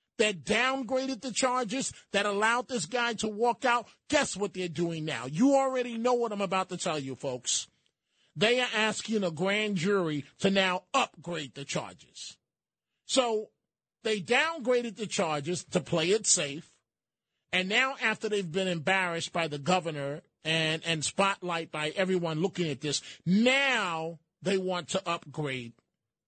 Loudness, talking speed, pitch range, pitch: -29 LUFS, 155 wpm, 165-235 Hz, 195 Hz